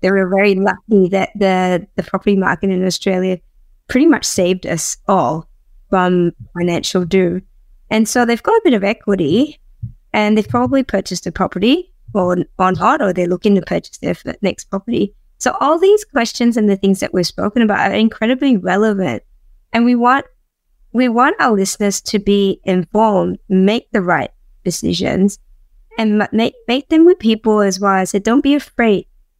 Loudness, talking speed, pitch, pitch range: -15 LUFS, 175 wpm, 200 Hz, 185-230 Hz